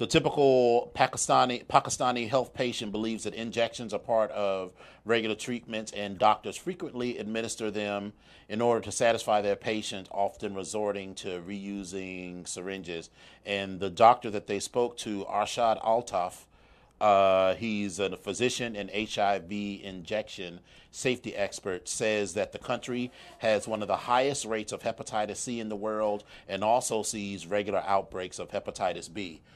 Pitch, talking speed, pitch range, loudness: 105 Hz, 145 wpm, 100-115 Hz, -29 LUFS